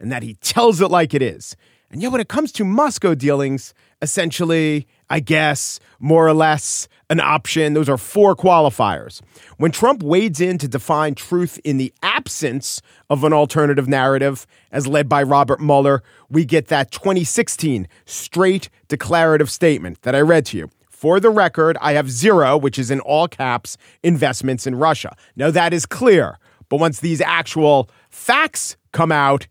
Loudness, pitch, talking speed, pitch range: -17 LUFS, 150 Hz, 170 wpm, 140-170 Hz